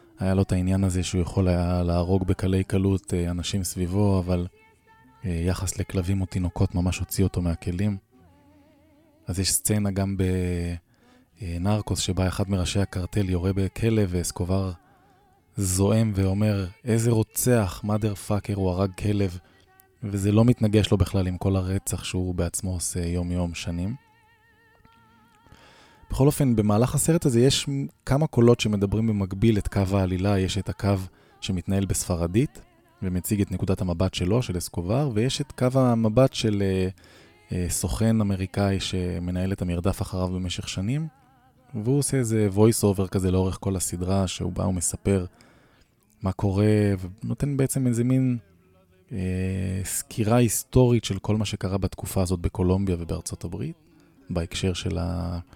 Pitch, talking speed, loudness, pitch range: 95 Hz, 140 wpm, -25 LUFS, 90-110 Hz